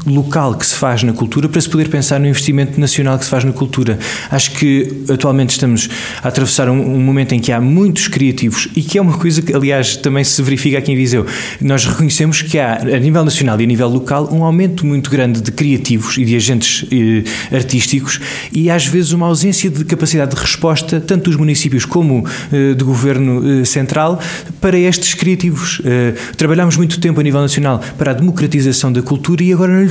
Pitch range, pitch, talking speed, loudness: 130-160 Hz, 140 Hz, 205 wpm, -12 LUFS